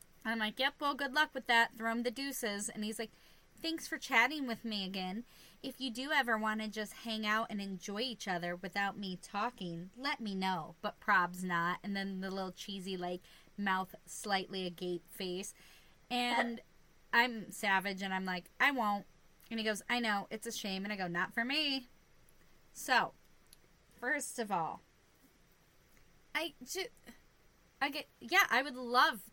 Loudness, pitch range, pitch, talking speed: -36 LUFS, 190-245 Hz, 215 Hz, 180 wpm